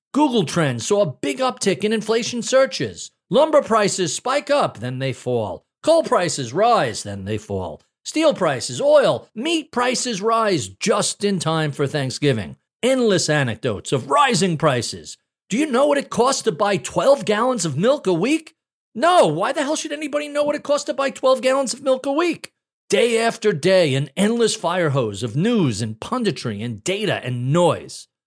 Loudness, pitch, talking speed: -20 LUFS, 210 Hz, 180 wpm